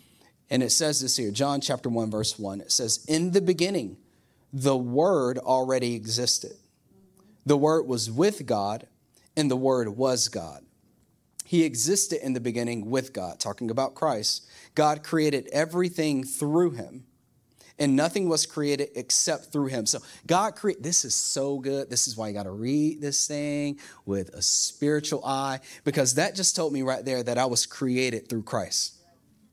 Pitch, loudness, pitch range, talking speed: 135 Hz, -26 LUFS, 120-150 Hz, 170 wpm